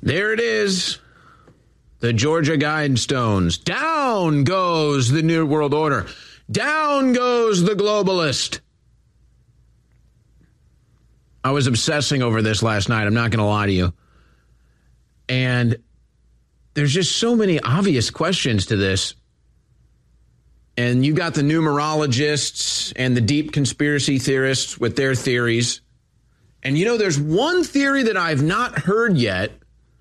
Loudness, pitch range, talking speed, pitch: -19 LUFS, 115-165 Hz, 125 wpm, 135 Hz